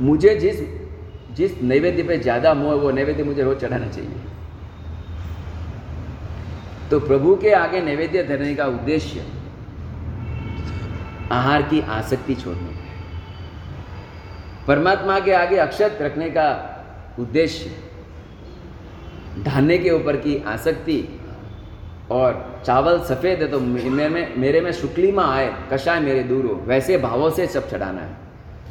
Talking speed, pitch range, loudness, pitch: 120 wpm, 95-150 Hz, -20 LUFS, 125 Hz